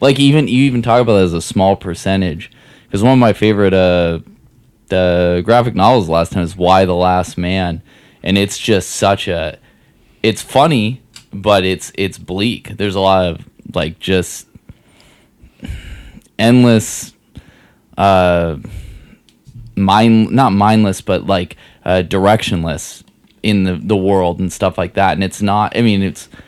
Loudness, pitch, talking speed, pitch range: -14 LUFS, 95 Hz, 155 wpm, 90-110 Hz